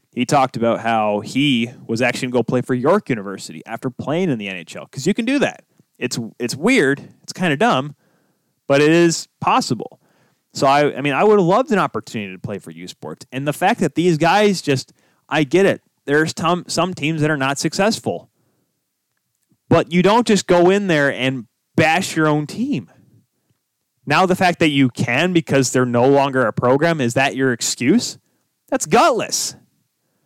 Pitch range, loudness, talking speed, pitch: 125-175 Hz, -17 LUFS, 190 wpm, 145 Hz